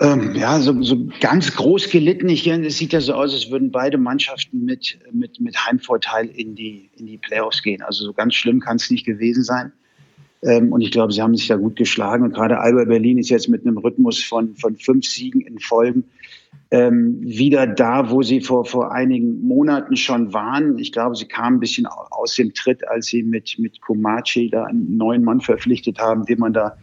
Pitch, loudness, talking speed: 130 Hz, -18 LUFS, 215 wpm